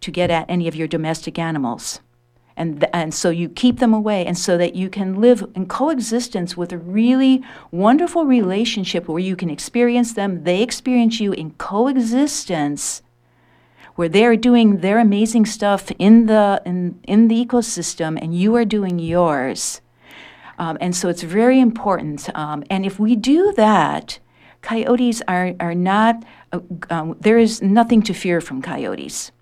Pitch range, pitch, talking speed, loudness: 170-230 Hz, 195 Hz, 165 wpm, -18 LUFS